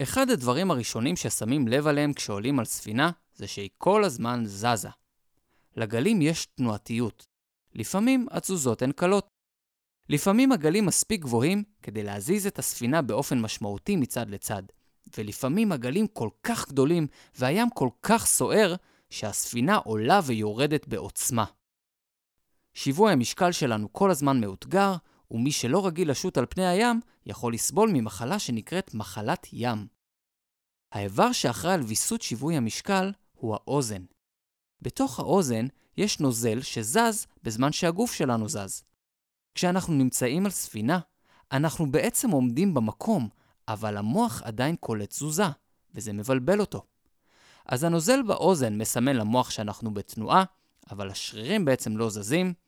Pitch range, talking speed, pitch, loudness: 110-185 Hz, 125 wpm, 135 Hz, -26 LUFS